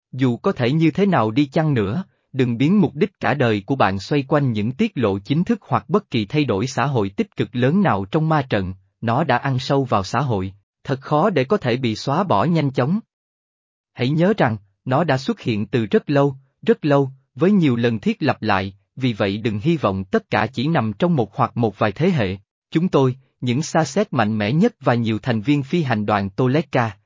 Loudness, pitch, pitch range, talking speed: -20 LUFS, 130 Hz, 110-160 Hz, 235 wpm